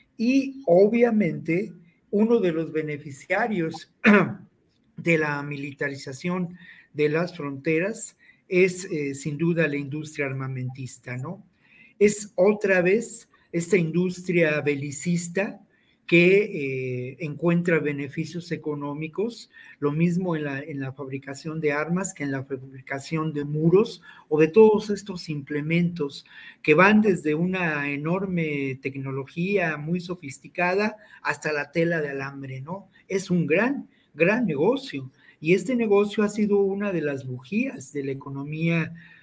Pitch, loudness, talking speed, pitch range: 165 Hz, -24 LUFS, 125 wpm, 145-195 Hz